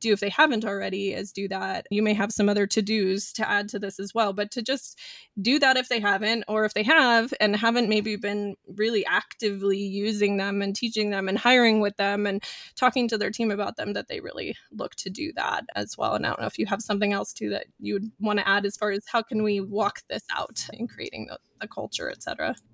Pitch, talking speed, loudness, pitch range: 210 Hz, 250 wpm, -25 LUFS, 200-230 Hz